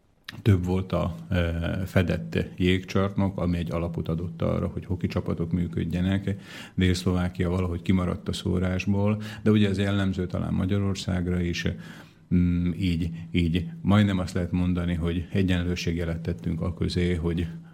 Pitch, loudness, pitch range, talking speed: 90 Hz, -27 LUFS, 85-95 Hz, 130 wpm